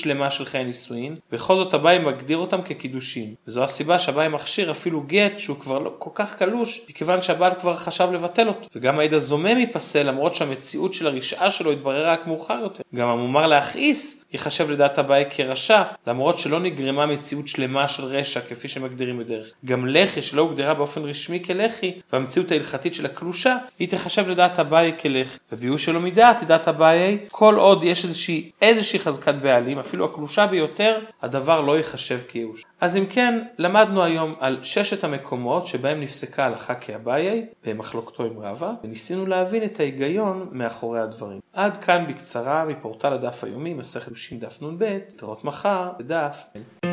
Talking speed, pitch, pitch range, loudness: 150 wpm, 155 Hz, 135-185 Hz, -21 LUFS